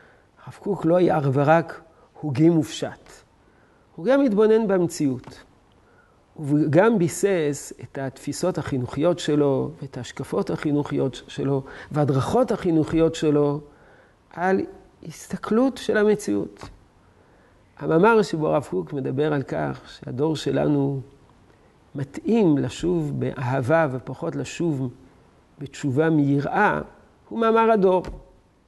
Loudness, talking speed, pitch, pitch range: -22 LUFS, 105 wpm, 150 Hz, 135-175 Hz